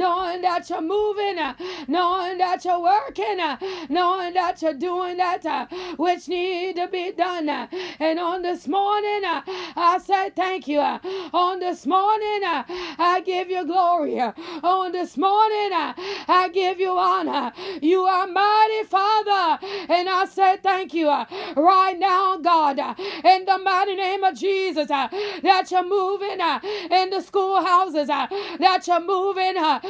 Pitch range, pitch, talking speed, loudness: 345-380 Hz, 365 Hz, 135 wpm, -22 LUFS